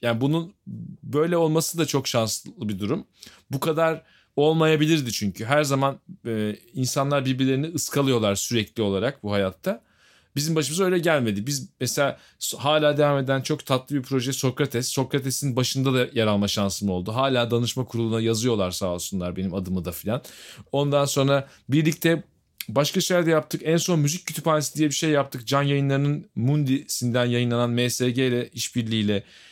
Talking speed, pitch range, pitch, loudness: 150 wpm, 115-150 Hz, 135 Hz, -24 LUFS